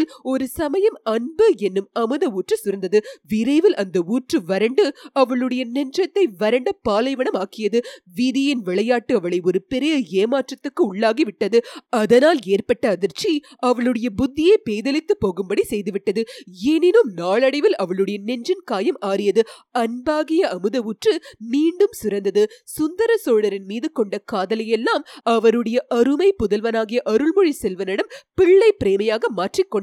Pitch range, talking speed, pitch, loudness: 210-310 Hz, 110 wpm, 245 Hz, -20 LUFS